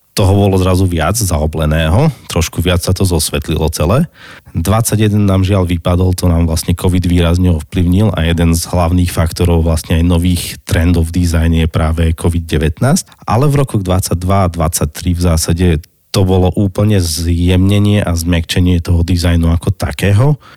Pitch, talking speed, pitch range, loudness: 90 Hz, 155 wpm, 85-95 Hz, -13 LUFS